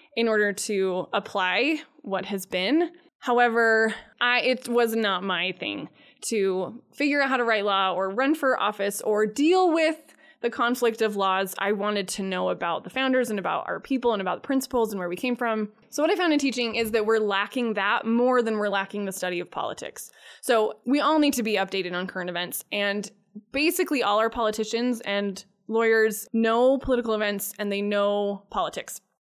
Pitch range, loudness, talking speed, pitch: 200-250 Hz, -25 LUFS, 195 wpm, 220 Hz